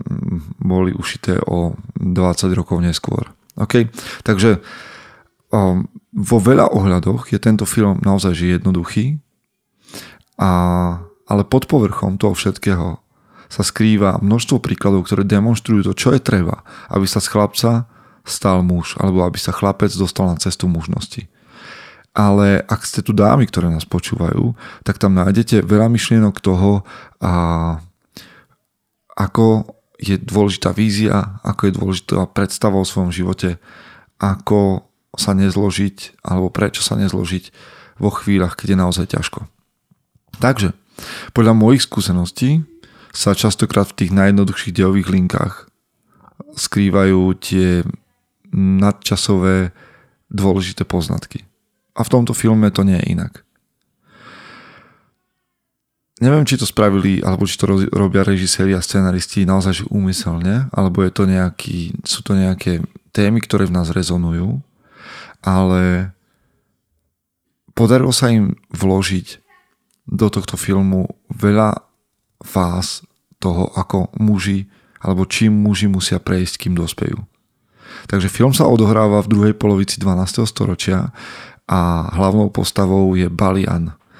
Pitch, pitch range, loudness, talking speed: 100 Hz, 95-105 Hz, -16 LUFS, 120 wpm